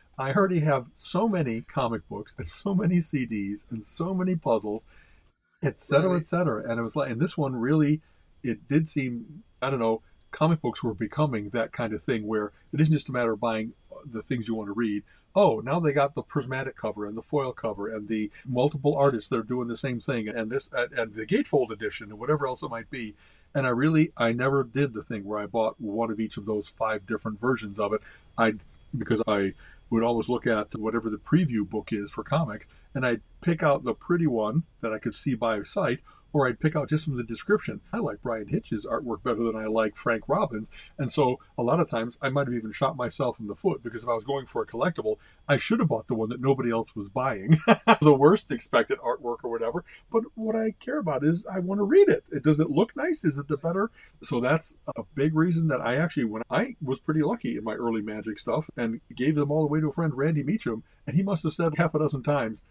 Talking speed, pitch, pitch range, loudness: 240 wpm, 130 Hz, 110-155 Hz, -27 LUFS